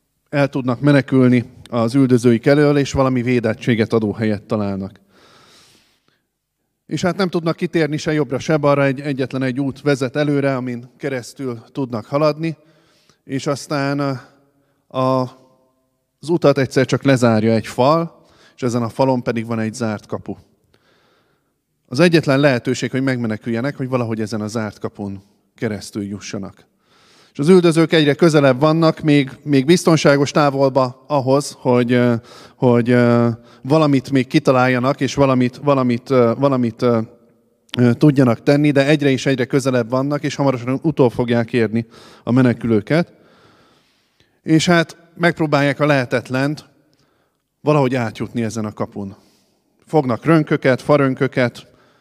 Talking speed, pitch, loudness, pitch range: 130 wpm, 130 Hz, -17 LUFS, 120-145 Hz